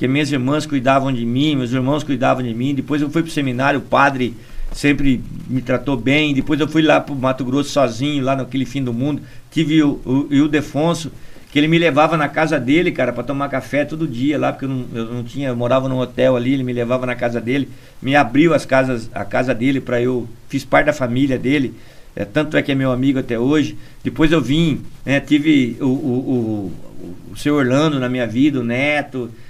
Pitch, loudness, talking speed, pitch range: 135 Hz, -18 LUFS, 225 wpm, 125-145 Hz